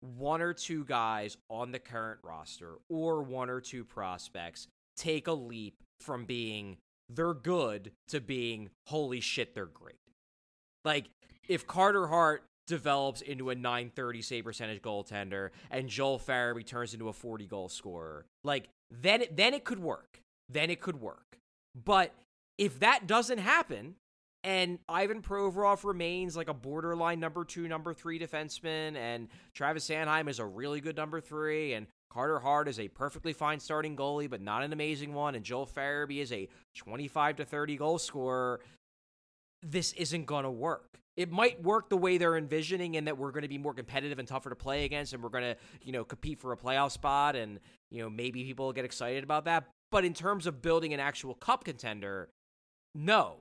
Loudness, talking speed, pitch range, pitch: -34 LUFS, 185 wpm, 120-165 Hz, 145 Hz